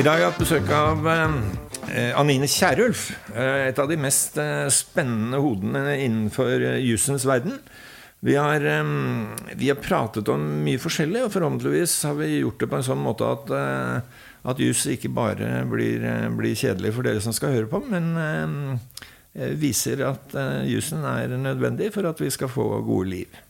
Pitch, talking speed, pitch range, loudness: 135 Hz, 160 wpm, 110-150 Hz, -23 LUFS